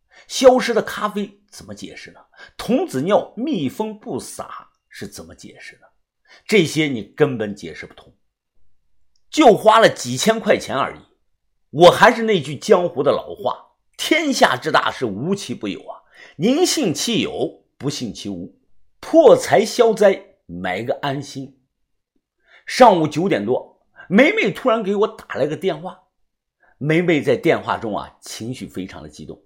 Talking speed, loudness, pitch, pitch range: 220 characters per minute, -18 LUFS, 195 Hz, 135-220 Hz